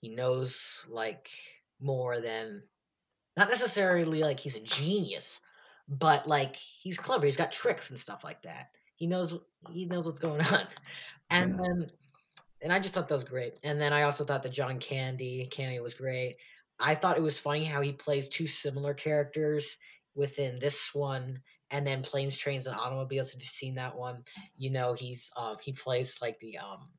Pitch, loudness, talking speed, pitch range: 140 Hz, -31 LUFS, 185 wpm, 130-160 Hz